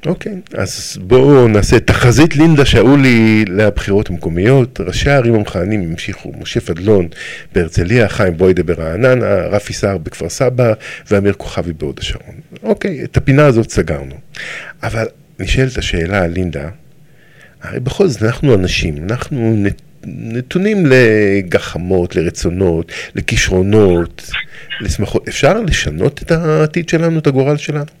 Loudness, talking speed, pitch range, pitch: -13 LUFS, 120 wpm, 90-140 Hz, 110 Hz